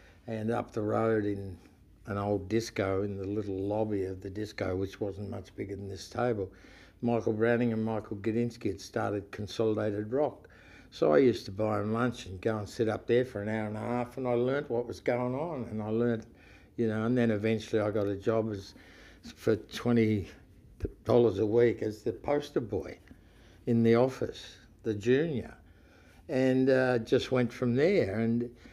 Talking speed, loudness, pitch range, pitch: 190 wpm, -31 LUFS, 100-120 Hz, 110 Hz